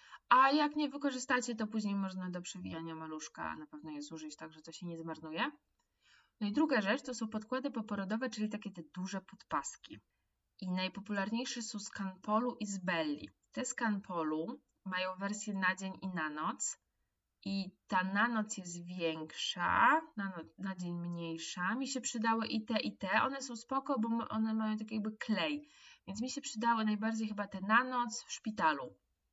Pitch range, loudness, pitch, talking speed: 185-235 Hz, -36 LUFS, 210 Hz, 180 wpm